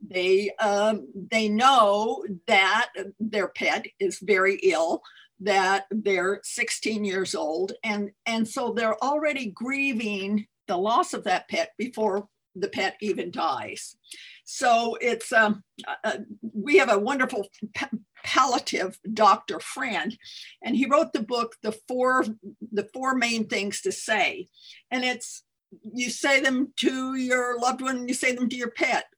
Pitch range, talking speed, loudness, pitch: 205-260 Hz, 145 wpm, -25 LUFS, 225 Hz